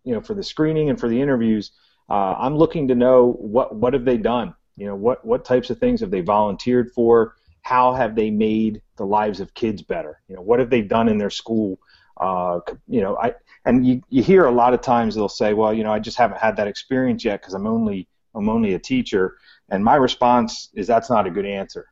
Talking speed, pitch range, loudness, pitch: 240 wpm, 105-130 Hz, -20 LUFS, 120 Hz